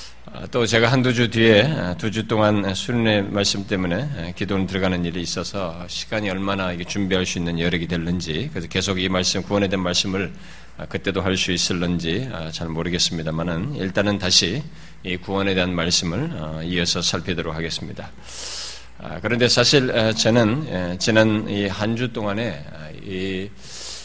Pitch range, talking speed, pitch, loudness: 85-105 Hz, 315 characters per minute, 95 Hz, -21 LUFS